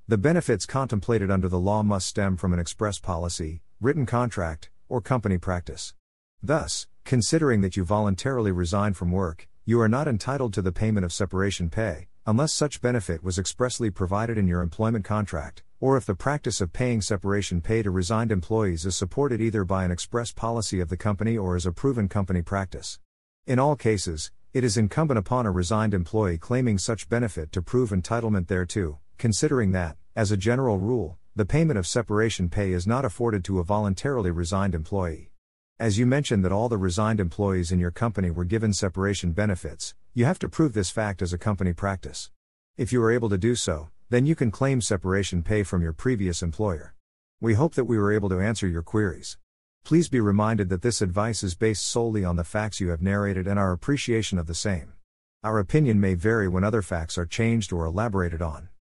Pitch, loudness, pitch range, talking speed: 100 Hz, -25 LUFS, 90-115 Hz, 195 wpm